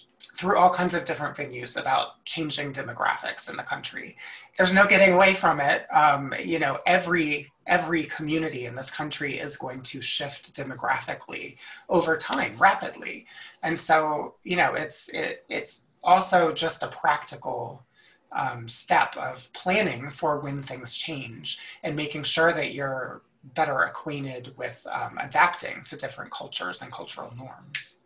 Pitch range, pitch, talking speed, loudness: 135-165 Hz, 150 Hz, 150 wpm, -25 LUFS